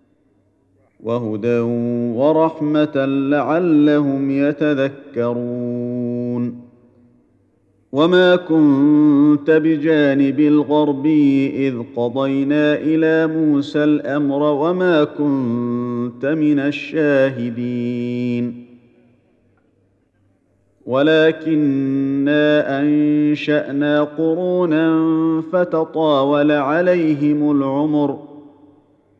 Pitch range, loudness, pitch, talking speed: 120-150 Hz, -17 LUFS, 145 Hz, 45 wpm